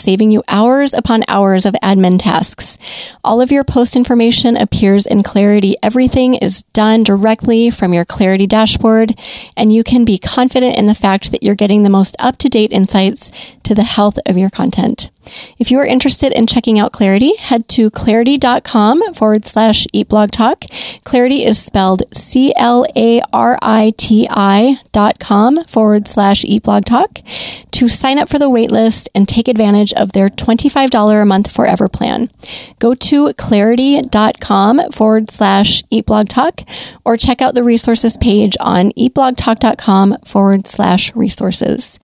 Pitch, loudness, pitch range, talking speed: 220 Hz, -10 LUFS, 205-245 Hz, 155 wpm